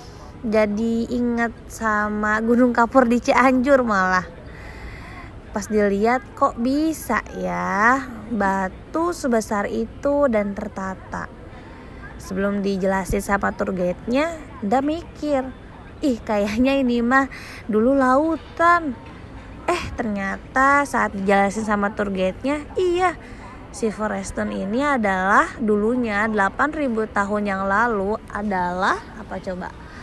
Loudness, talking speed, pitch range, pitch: -21 LUFS, 100 wpm, 200-265 Hz, 220 Hz